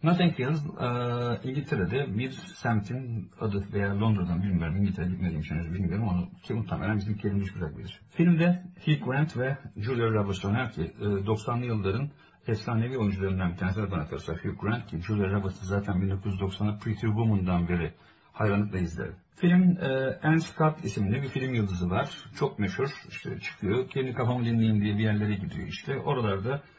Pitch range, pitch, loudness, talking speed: 95-130 Hz, 105 Hz, -29 LUFS, 170 wpm